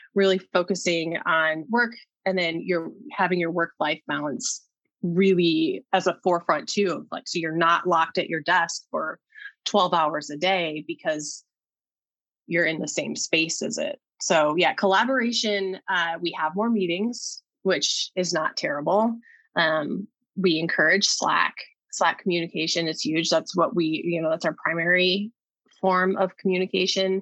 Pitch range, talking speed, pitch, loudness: 165-205 Hz, 150 wpm, 185 Hz, -24 LUFS